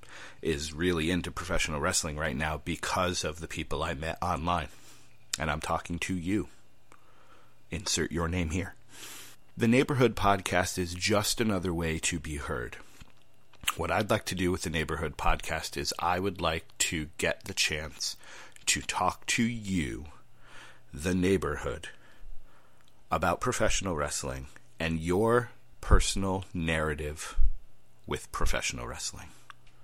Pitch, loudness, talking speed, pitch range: 90 Hz, -30 LUFS, 135 wpm, 80-95 Hz